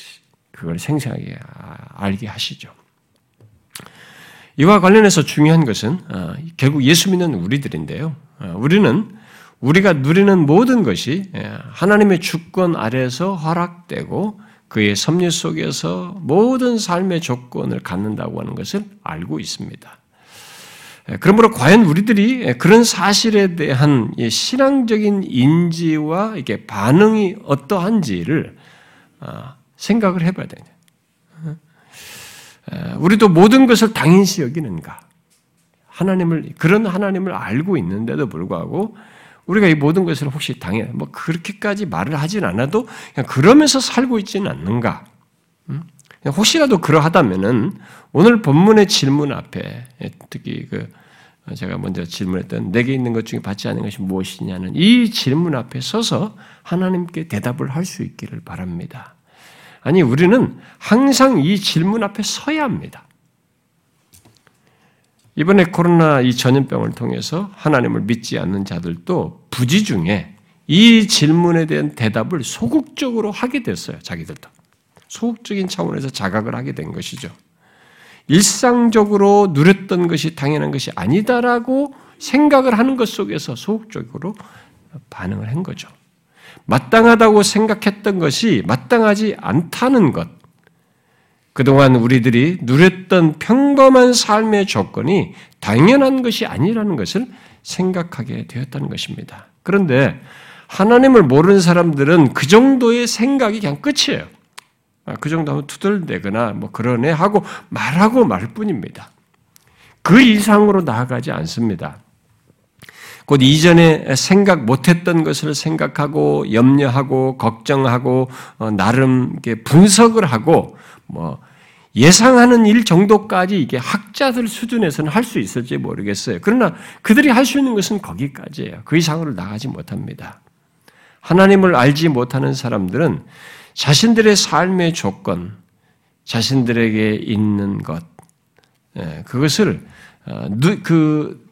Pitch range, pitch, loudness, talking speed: 140-210 Hz, 175 Hz, -15 LUFS, 275 characters per minute